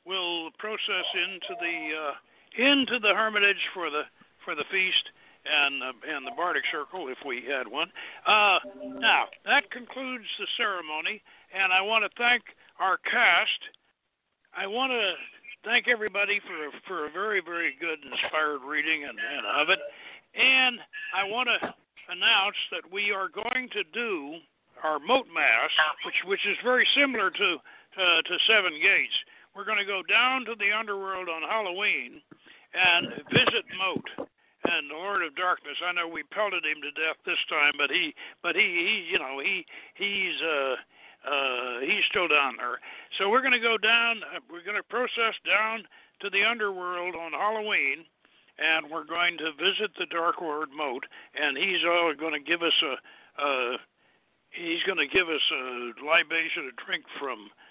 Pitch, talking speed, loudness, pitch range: 205 Hz, 170 wpm, -26 LUFS, 170-245 Hz